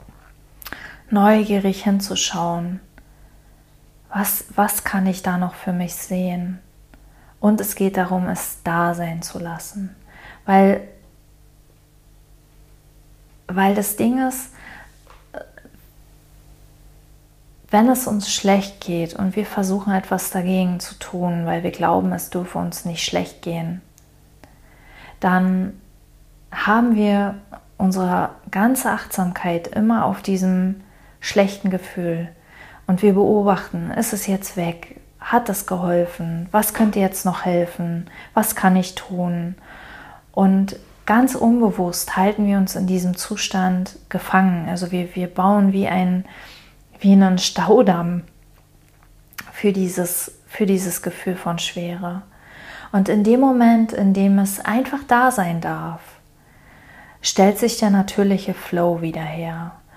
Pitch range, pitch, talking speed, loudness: 175-205 Hz, 190 Hz, 120 wpm, -20 LUFS